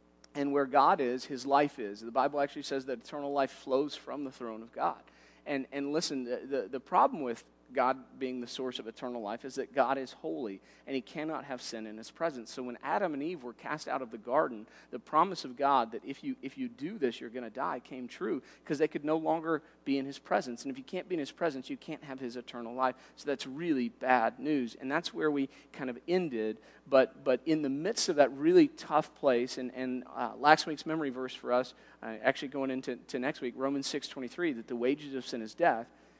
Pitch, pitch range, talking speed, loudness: 135 Hz, 125-150 Hz, 245 wpm, -33 LUFS